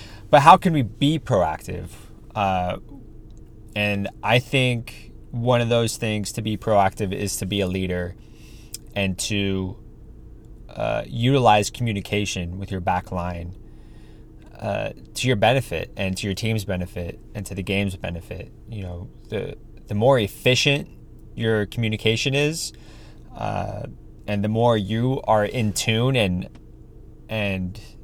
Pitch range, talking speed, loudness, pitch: 100-115 Hz, 135 wpm, -22 LUFS, 110 Hz